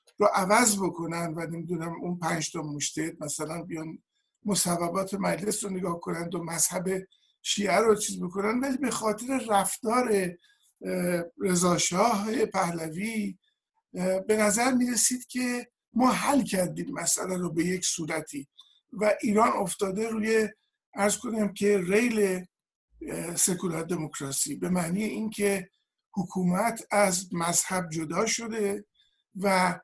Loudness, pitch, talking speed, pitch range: -27 LUFS, 195 Hz, 115 wpm, 175-220 Hz